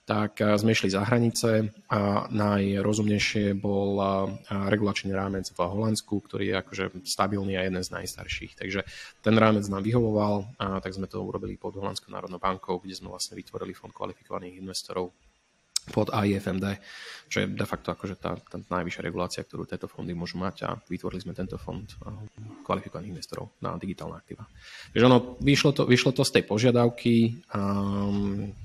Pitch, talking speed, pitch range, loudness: 100 Hz, 160 wpm, 95-105 Hz, -27 LUFS